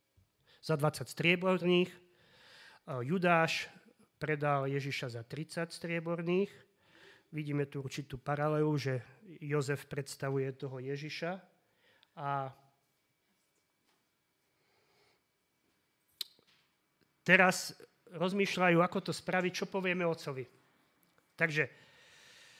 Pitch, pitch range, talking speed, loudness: 160 Hz, 140-180 Hz, 75 wpm, -34 LUFS